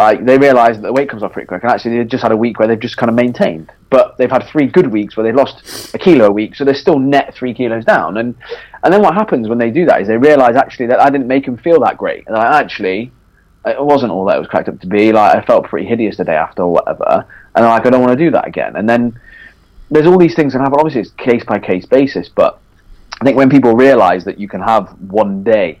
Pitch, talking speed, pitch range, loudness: 120 Hz, 285 wpm, 110-135 Hz, -12 LUFS